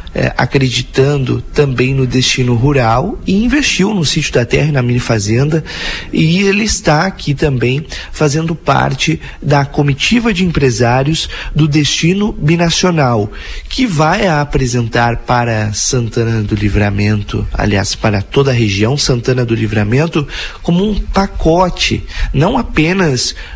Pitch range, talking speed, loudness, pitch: 120-160 Hz, 125 wpm, -13 LUFS, 140 Hz